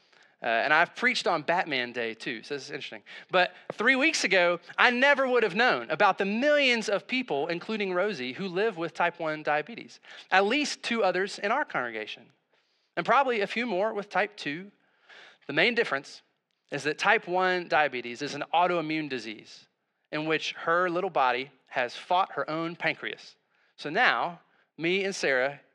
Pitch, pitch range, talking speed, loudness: 180 Hz, 150-215 Hz, 175 wpm, -27 LUFS